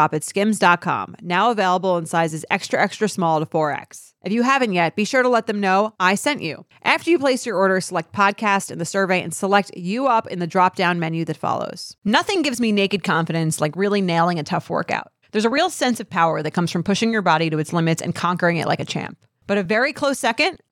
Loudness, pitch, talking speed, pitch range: -20 LUFS, 190 Hz, 240 wpm, 170-220 Hz